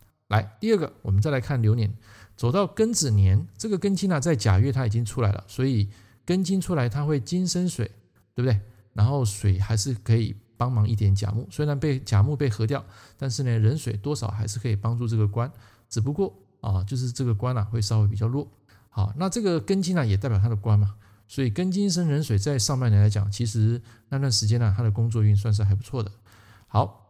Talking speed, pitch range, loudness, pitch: 325 characters per minute, 105-140 Hz, -25 LUFS, 115 Hz